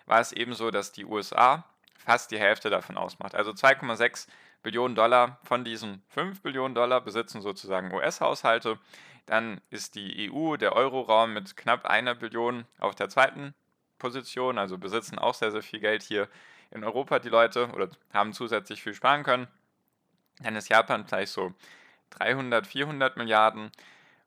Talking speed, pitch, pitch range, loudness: 155 wpm, 120 Hz, 110-125 Hz, -27 LUFS